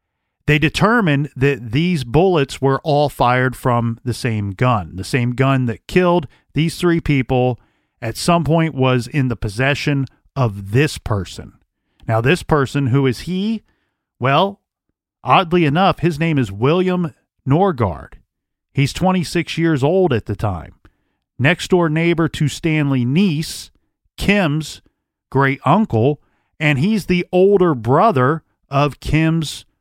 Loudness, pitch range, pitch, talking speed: -17 LUFS, 125-165 Hz, 145 Hz, 135 wpm